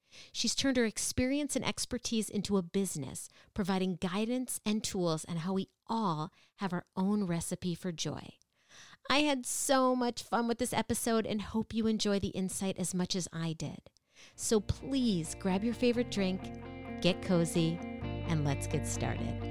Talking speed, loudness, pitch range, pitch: 165 wpm, -33 LUFS, 175-235 Hz, 195 Hz